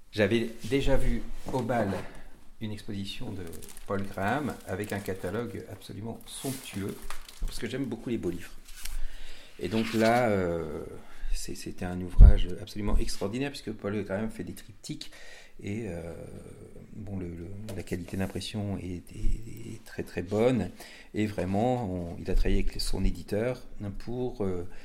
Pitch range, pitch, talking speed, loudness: 95-115 Hz, 100 Hz, 150 wpm, -32 LUFS